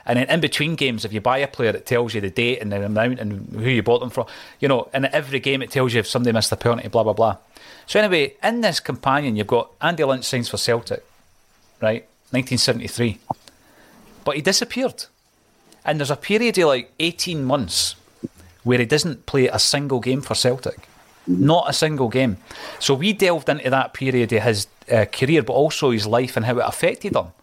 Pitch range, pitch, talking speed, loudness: 115-145 Hz, 125 Hz, 210 wpm, -20 LUFS